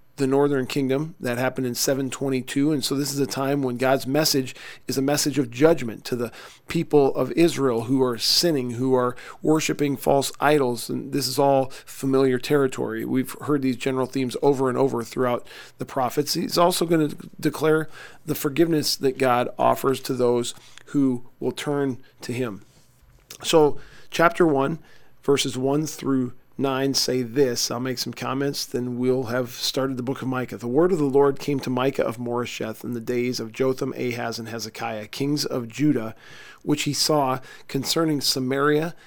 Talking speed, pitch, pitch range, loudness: 175 wpm, 135 Hz, 125-145 Hz, -23 LUFS